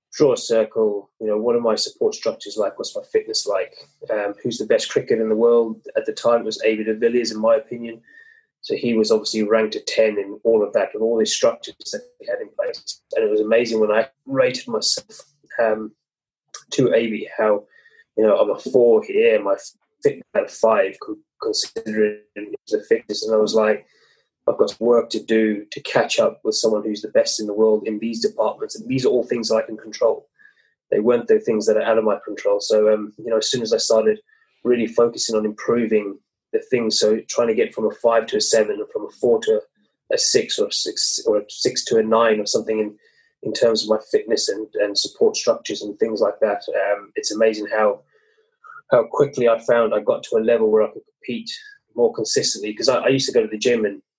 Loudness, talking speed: -20 LUFS, 230 wpm